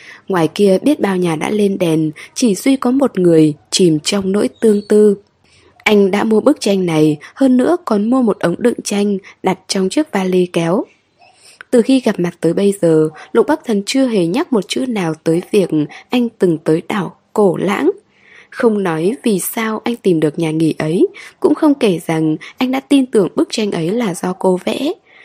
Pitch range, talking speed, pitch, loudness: 175-245 Hz, 205 wpm, 200 Hz, -15 LUFS